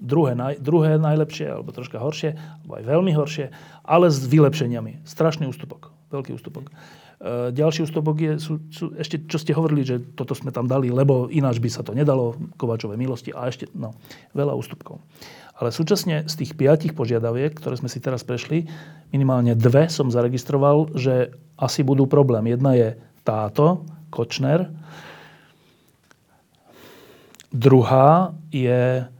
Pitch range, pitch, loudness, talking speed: 125-155 Hz, 145 Hz, -21 LUFS, 140 wpm